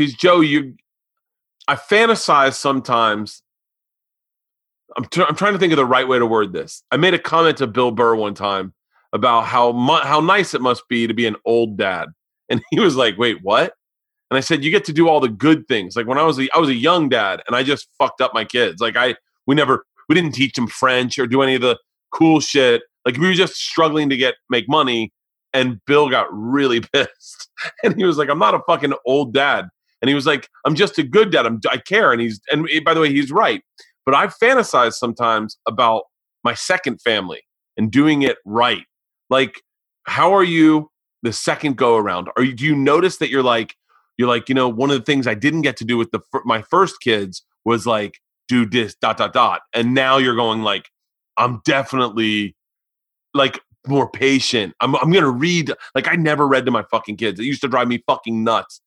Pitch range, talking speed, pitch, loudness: 115-155 Hz, 220 wpm, 135 Hz, -17 LUFS